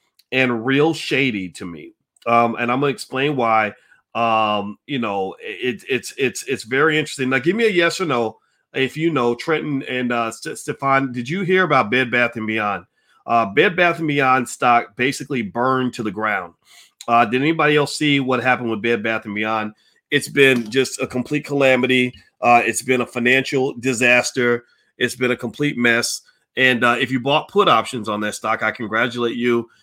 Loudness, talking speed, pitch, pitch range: -19 LUFS, 195 wpm, 125 Hz, 115-140 Hz